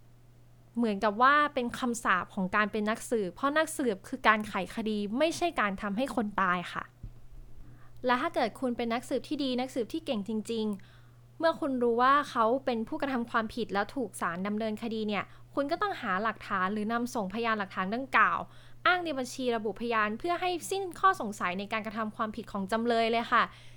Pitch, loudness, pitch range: 225 Hz, -30 LUFS, 205-260 Hz